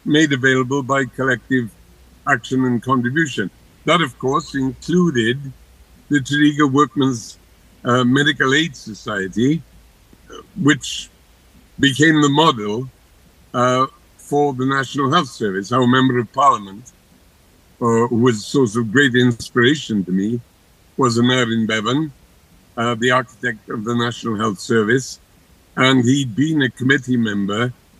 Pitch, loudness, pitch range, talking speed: 125 Hz, -18 LUFS, 100-135 Hz, 125 wpm